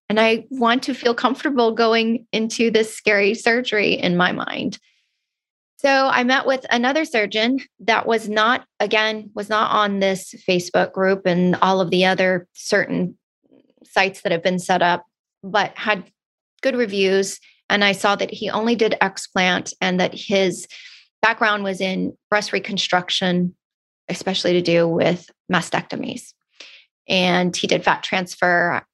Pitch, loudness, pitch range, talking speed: 205 Hz, -19 LUFS, 185-230 Hz, 150 wpm